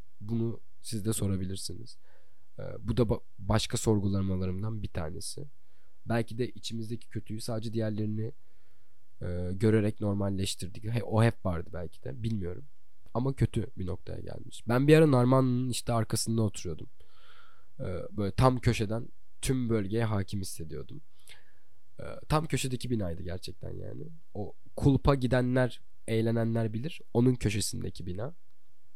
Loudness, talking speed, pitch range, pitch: -31 LUFS, 115 wpm, 100-120 Hz, 110 Hz